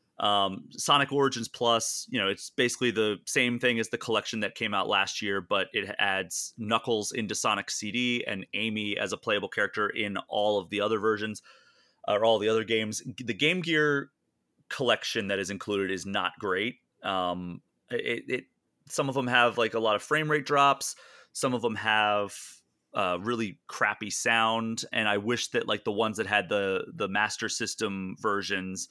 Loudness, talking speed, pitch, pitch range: -28 LUFS, 185 wpm, 110 Hz, 105-125 Hz